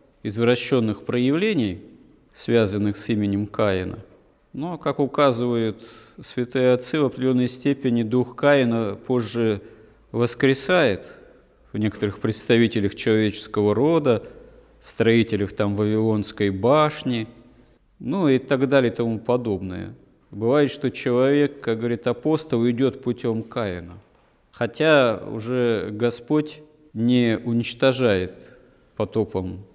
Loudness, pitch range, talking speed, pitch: -22 LUFS, 110-135 Hz, 100 wpm, 120 Hz